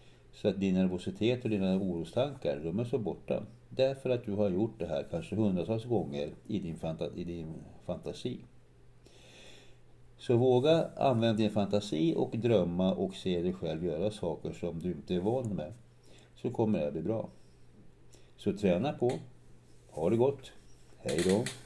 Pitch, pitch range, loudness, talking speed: 105 Hz, 90-125 Hz, -32 LUFS, 165 wpm